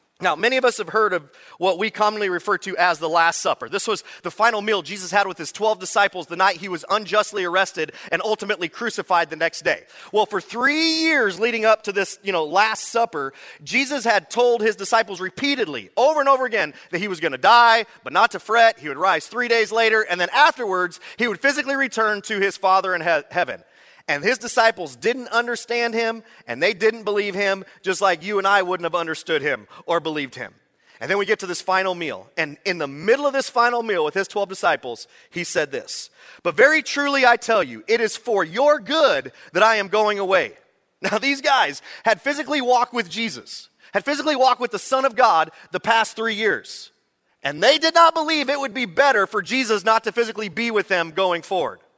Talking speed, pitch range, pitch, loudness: 220 wpm, 190-240 Hz, 215 Hz, -20 LUFS